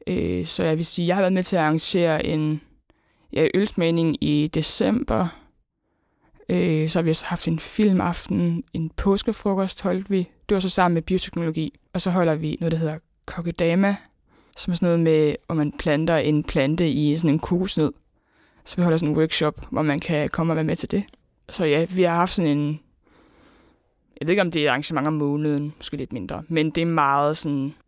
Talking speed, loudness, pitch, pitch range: 200 wpm, -22 LUFS, 160 Hz, 150-180 Hz